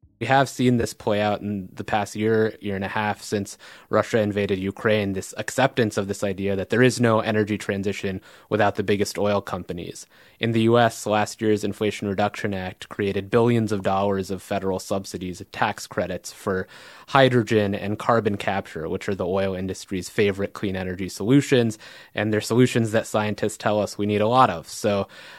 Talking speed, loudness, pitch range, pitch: 185 wpm, -23 LUFS, 100-110 Hz, 105 Hz